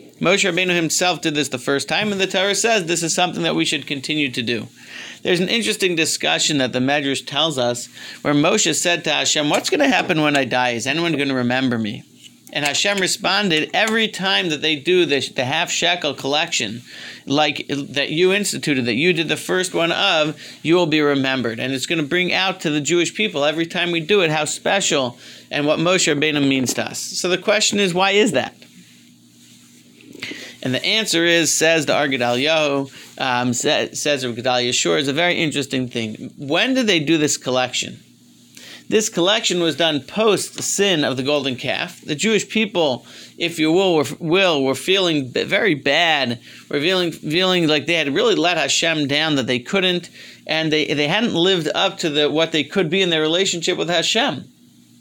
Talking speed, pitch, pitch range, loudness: 195 wpm, 155 Hz, 135-180 Hz, -18 LUFS